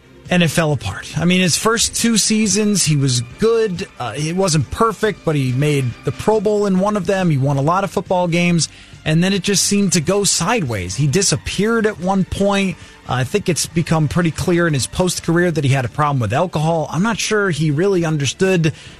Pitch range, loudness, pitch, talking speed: 150-200 Hz, -17 LUFS, 175 Hz, 225 wpm